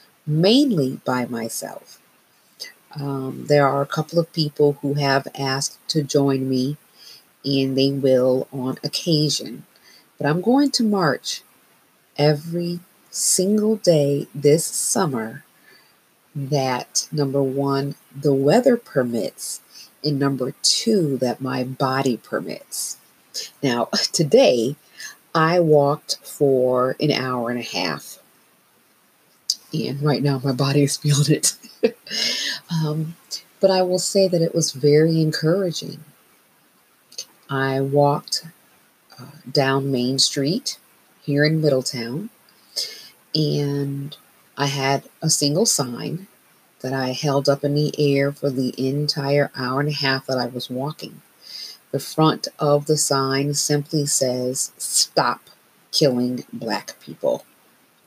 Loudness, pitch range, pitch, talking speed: -21 LUFS, 135-155 Hz, 145 Hz, 120 wpm